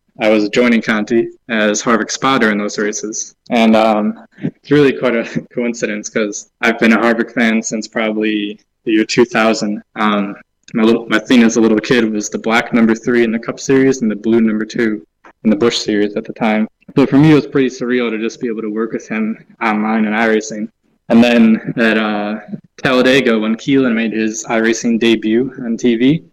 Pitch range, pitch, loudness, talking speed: 110-120 Hz, 115 Hz, -14 LUFS, 200 wpm